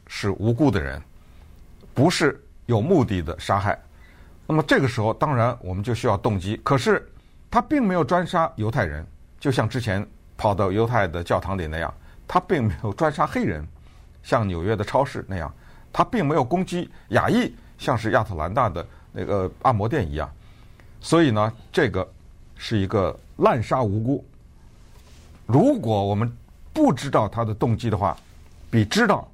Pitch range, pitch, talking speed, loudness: 85-130 Hz, 105 Hz, 245 characters per minute, -23 LUFS